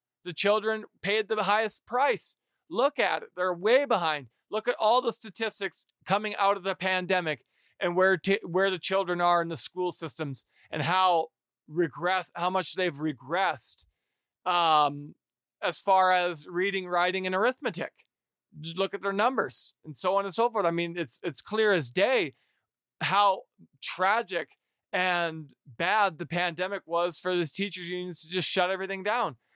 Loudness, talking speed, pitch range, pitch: -28 LUFS, 165 wpm, 170-200 Hz, 185 Hz